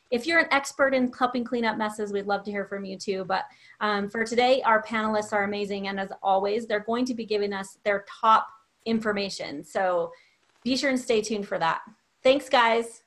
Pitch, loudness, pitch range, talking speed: 220 Hz, -26 LUFS, 200-245 Hz, 210 wpm